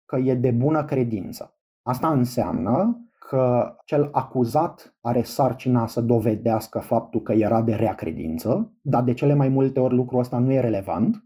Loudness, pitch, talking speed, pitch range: -23 LUFS, 125 Hz, 165 wpm, 115-135 Hz